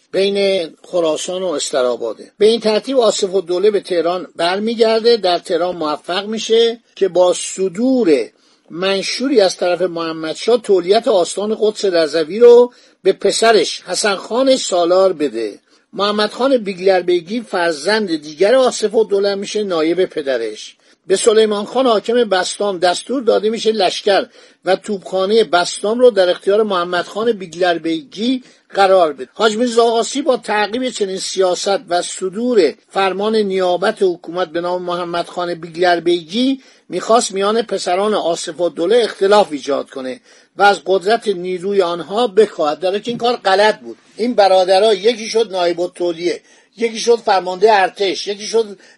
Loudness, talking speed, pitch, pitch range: -16 LUFS, 145 wpm, 195 Hz, 180-225 Hz